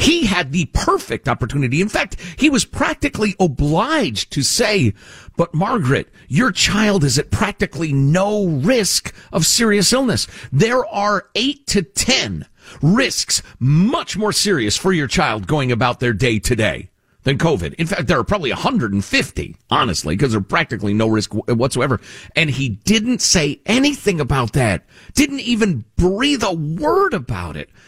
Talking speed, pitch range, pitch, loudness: 155 wpm, 125-210 Hz, 165 Hz, -17 LUFS